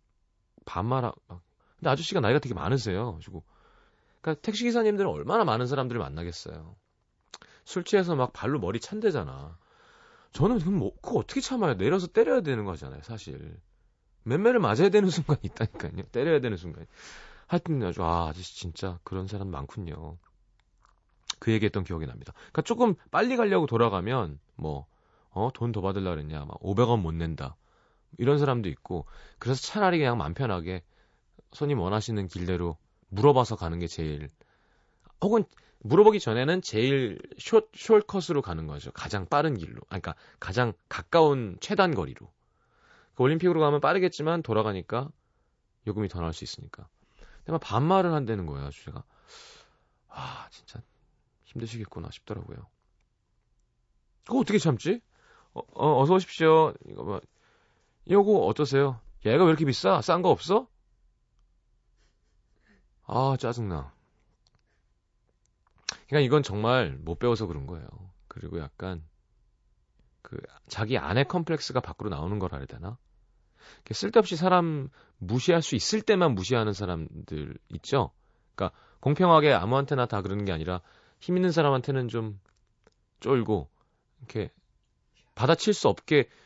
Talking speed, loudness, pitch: 310 characters per minute, -27 LUFS, 115 Hz